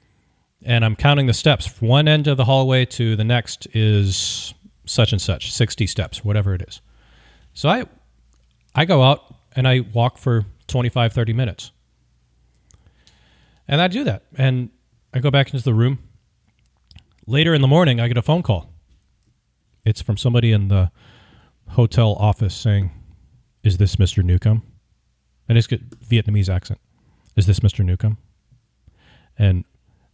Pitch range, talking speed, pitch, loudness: 100-125 Hz, 155 wpm, 110 Hz, -19 LUFS